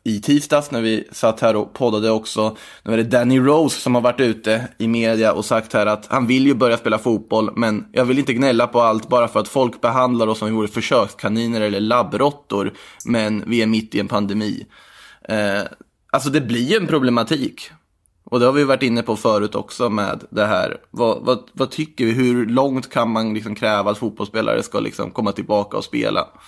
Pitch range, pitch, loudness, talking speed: 110-130 Hz, 115 Hz, -19 LUFS, 215 wpm